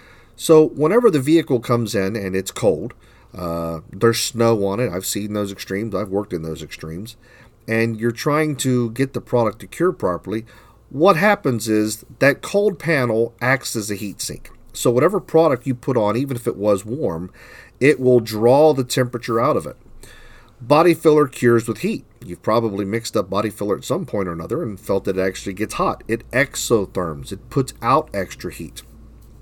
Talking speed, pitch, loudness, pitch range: 190 wpm, 115 Hz, -19 LUFS, 105-130 Hz